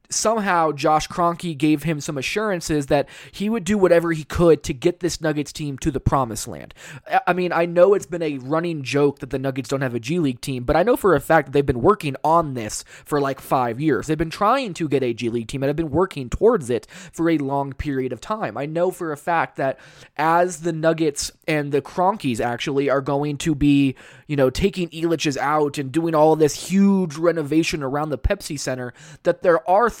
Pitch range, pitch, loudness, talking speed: 140-170 Hz, 155 Hz, -21 LUFS, 225 wpm